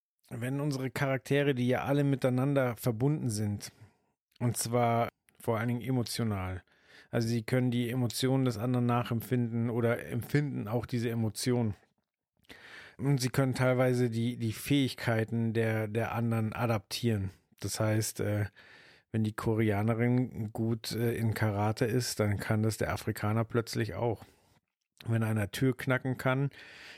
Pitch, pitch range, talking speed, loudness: 120 Hz, 110-125 Hz, 135 wpm, -31 LUFS